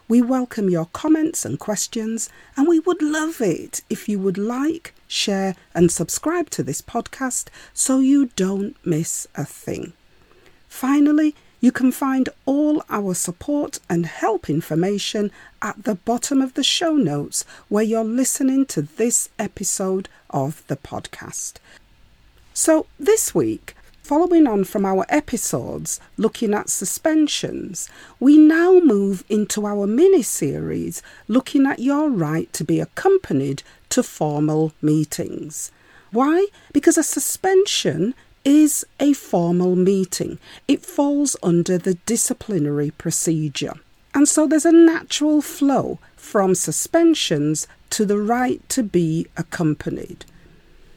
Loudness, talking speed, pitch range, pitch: -20 LUFS, 130 wpm, 175-295 Hz, 225 Hz